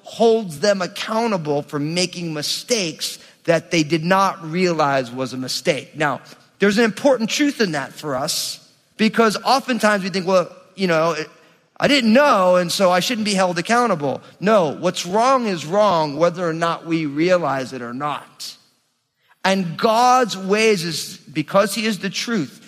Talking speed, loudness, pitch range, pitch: 165 wpm, -19 LUFS, 160-215 Hz, 180 Hz